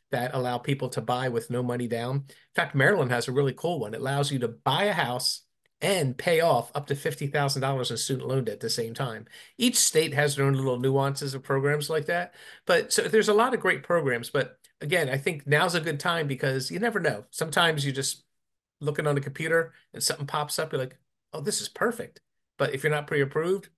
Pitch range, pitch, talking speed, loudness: 130-160 Hz, 140 Hz, 235 wpm, -27 LUFS